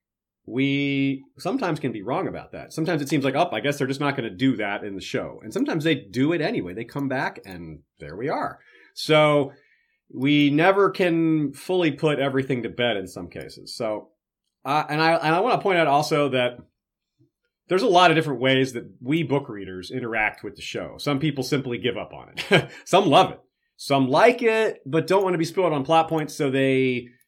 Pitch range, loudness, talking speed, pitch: 125-160 Hz, -22 LUFS, 220 wpm, 140 Hz